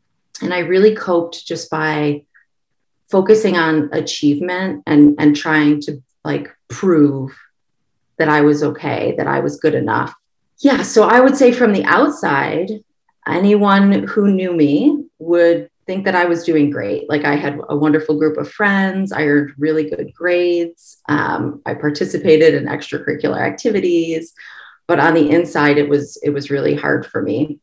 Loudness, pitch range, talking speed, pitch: -15 LUFS, 150-190 Hz, 160 wpm, 160 Hz